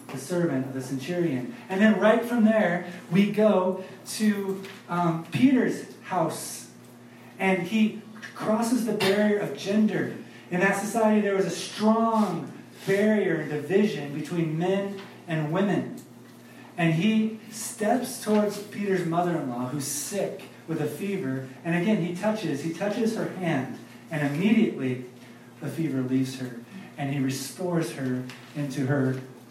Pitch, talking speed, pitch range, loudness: 175 Hz, 140 wpm, 140-205 Hz, -26 LUFS